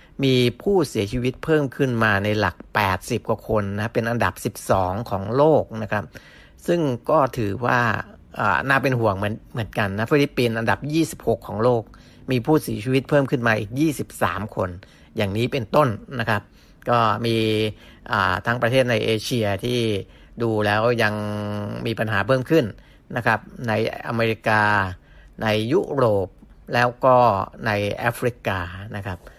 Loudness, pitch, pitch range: -22 LUFS, 115 Hz, 105-125 Hz